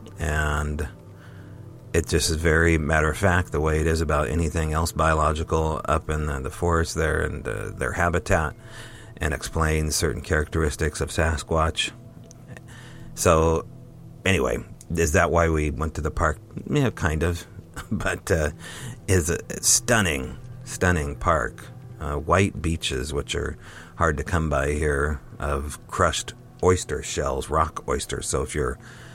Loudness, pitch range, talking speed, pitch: -24 LUFS, 75-95 Hz, 145 wpm, 85 Hz